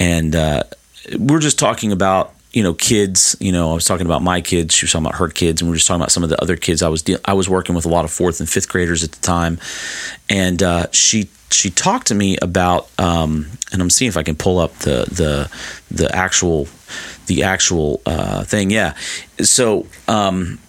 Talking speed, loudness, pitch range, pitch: 230 wpm, -16 LUFS, 85-95 Hz, 90 Hz